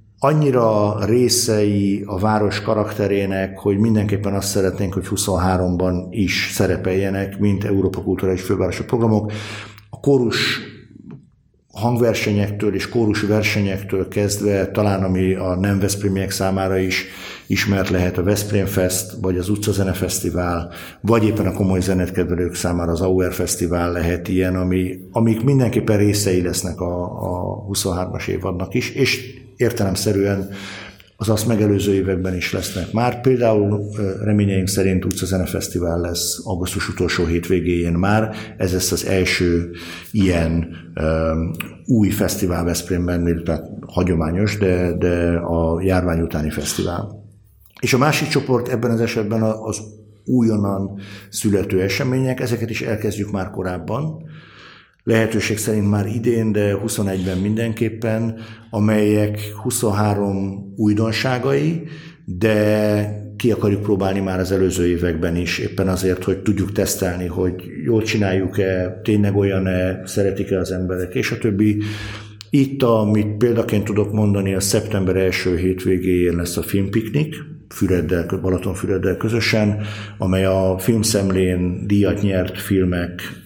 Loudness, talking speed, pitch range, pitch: -19 LUFS, 120 wpm, 90-110 Hz, 100 Hz